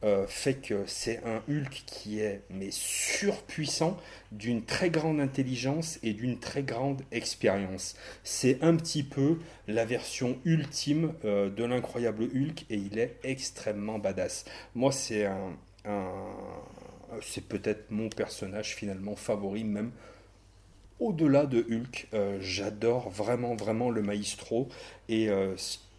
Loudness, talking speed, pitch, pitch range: -31 LUFS, 120 wpm, 115 Hz, 100-135 Hz